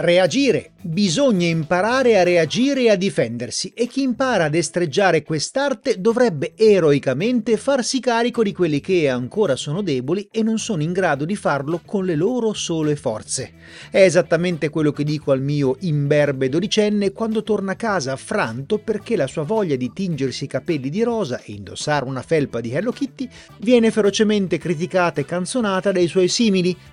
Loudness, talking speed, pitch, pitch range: -19 LUFS, 165 wpm, 180 Hz, 150-220 Hz